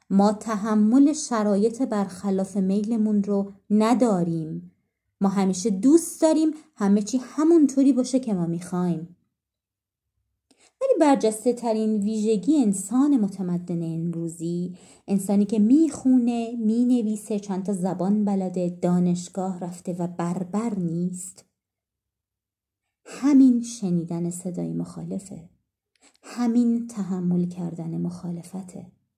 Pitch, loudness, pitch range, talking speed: 200 Hz, -23 LUFS, 175-235 Hz, 95 wpm